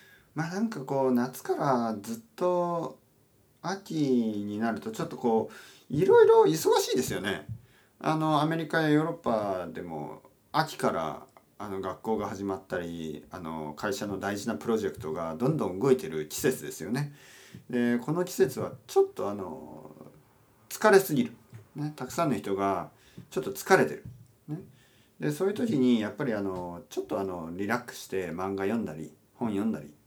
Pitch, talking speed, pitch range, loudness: 120 Hz, 325 characters per minute, 100-155 Hz, -29 LUFS